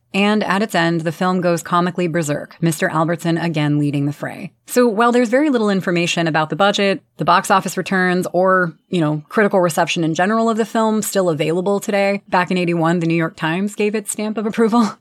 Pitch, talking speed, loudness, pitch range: 185 Hz, 210 wpm, -17 LUFS, 170-210 Hz